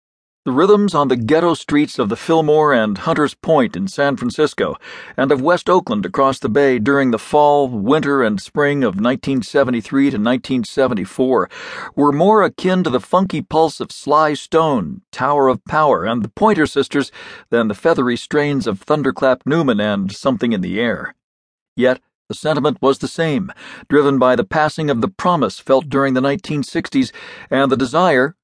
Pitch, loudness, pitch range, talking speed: 145 Hz, -16 LUFS, 130-160 Hz, 170 wpm